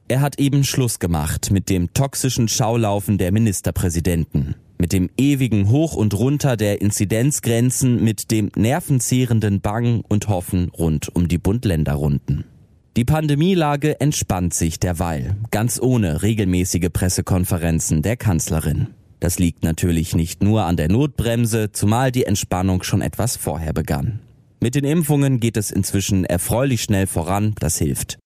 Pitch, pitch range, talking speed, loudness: 105 Hz, 90-120 Hz, 140 wpm, -19 LUFS